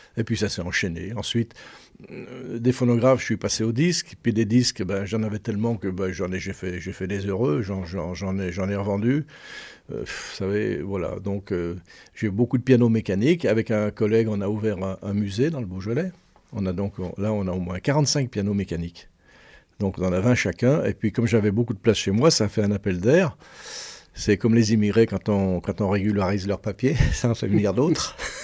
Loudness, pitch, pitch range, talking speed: -24 LUFS, 105 Hz, 95-120 Hz, 235 wpm